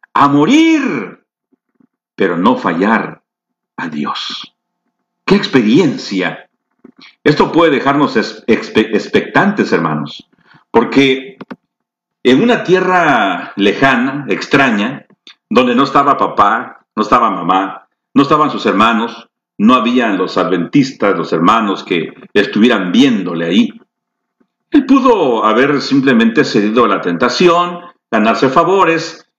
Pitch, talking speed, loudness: 185 Hz, 105 wpm, -12 LUFS